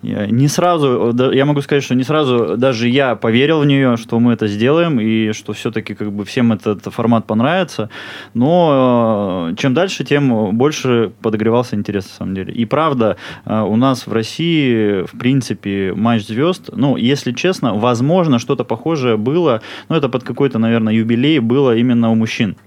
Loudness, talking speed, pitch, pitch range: -15 LUFS, 165 wpm, 120 Hz, 110-140 Hz